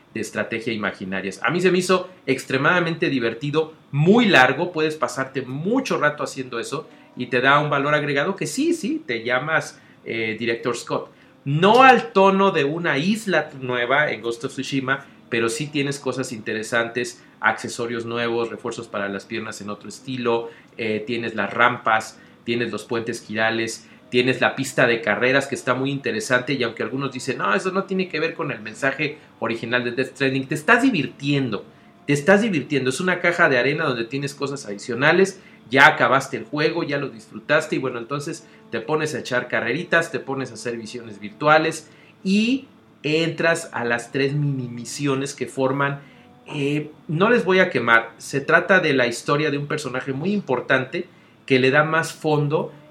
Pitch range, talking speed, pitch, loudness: 120-155 Hz, 180 wpm, 135 Hz, -21 LUFS